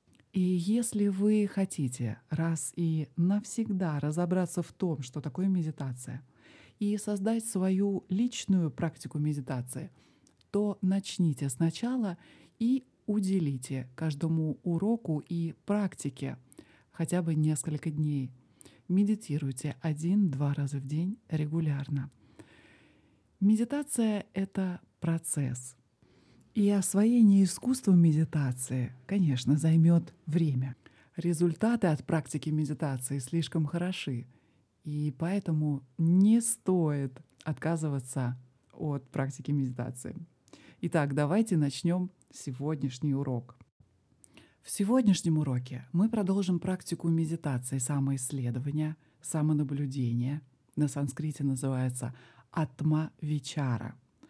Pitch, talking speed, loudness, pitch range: 155 Hz, 90 wpm, -31 LUFS, 140-185 Hz